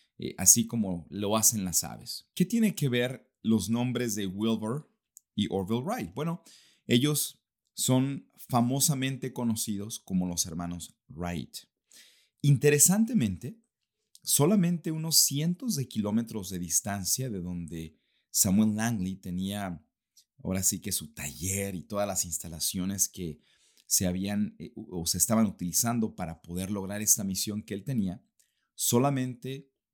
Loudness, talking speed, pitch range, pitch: -28 LUFS, 130 wpm, 95-130 Hz, 110 Hz